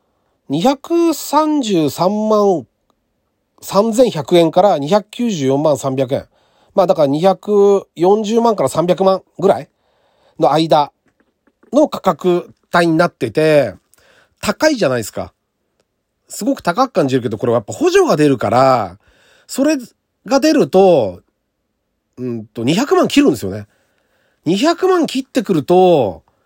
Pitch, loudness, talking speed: 190 Hz, -15 LUFS, 195 characters per minute